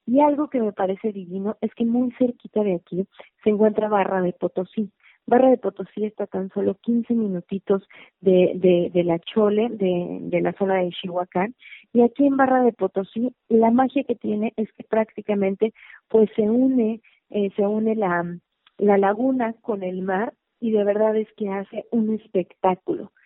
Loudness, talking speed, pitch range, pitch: -22 LUFS, 180 wpm, 190-230 Hz, 210 Hz